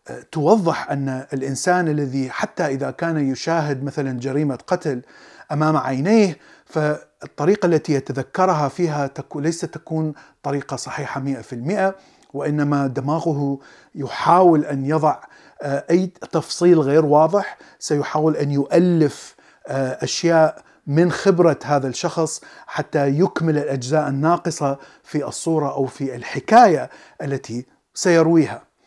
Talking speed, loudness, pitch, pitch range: 105 wpm, -20 LUFS, 150 Hz, 140-165 Hz